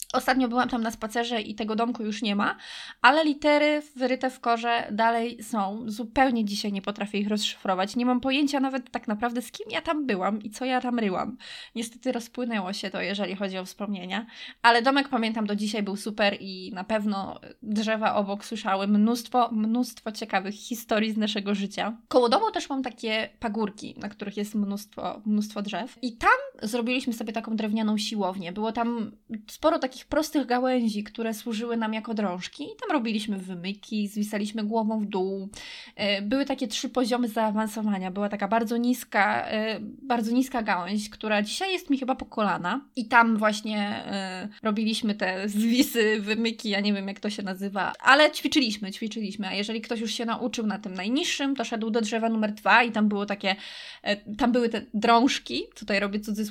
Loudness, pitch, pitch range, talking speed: -26 LUFS, 225 Hz, 205-245 Hz, 175 wpm